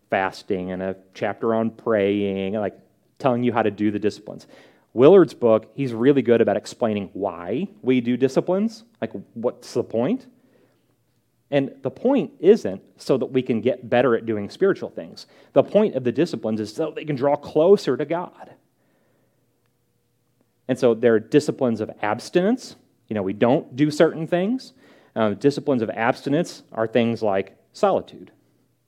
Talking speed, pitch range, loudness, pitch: 160 wpm, 110-150 Hz, -22 LUFS, 125 Hz